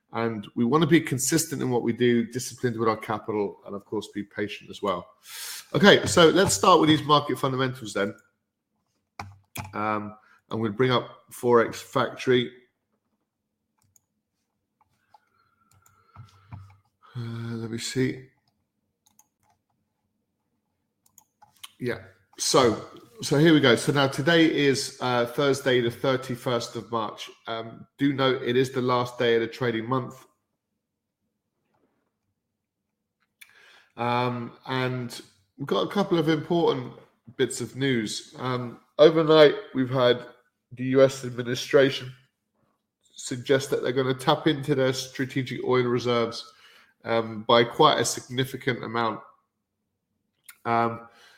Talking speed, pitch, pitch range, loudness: 125 wpm, 125 Hz, 115-130 Hz, -24 LUFS